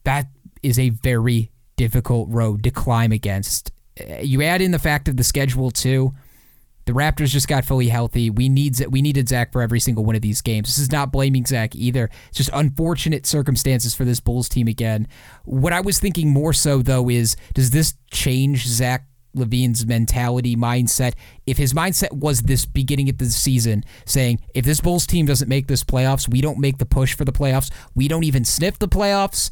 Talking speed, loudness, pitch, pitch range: 200 wpm, -19 LUFS, 130 Hz, 120-140 Hz